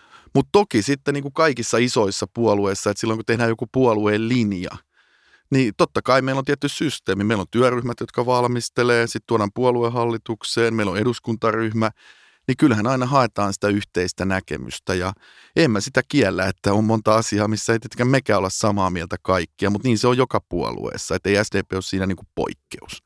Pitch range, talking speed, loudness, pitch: 100-125 Hz, 180 wpm, -21 LUFS, 115 Hz